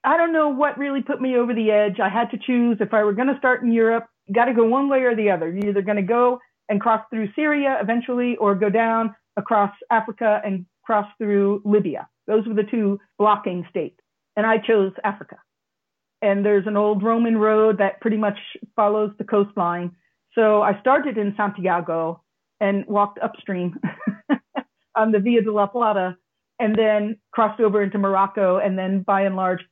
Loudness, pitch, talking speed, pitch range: -21 LUFS, 215 Hz, 195 wpm, 200-230 Hz